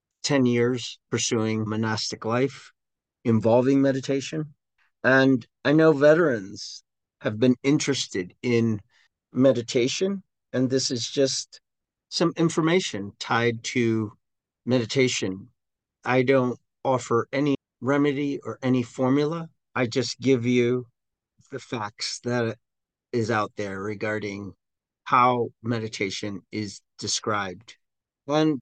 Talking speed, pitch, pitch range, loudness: 105 wpm, 125 Hz, 110-135 Hz, -24 LUFS